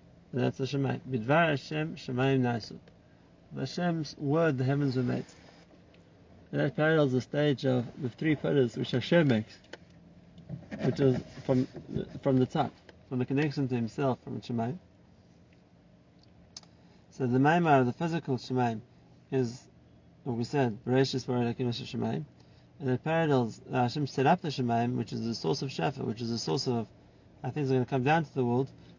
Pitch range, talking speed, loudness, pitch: 120-140 Hz, 180 wpm, -30 LUFS, 130 Hz